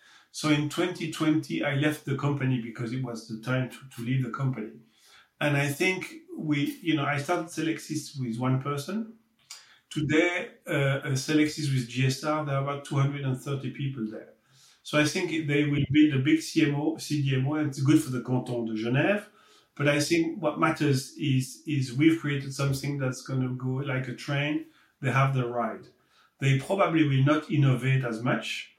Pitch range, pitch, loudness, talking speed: 130-155 Hz, 145 Hz, -28 LUFS, 180 wpm